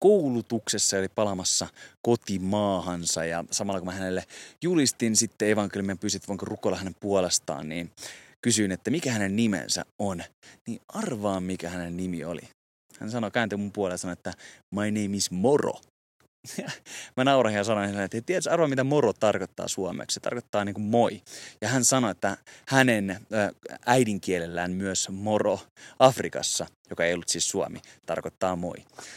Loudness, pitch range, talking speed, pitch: -27 LUFS, 95-115 Hz, 150 wpm, 100 Hz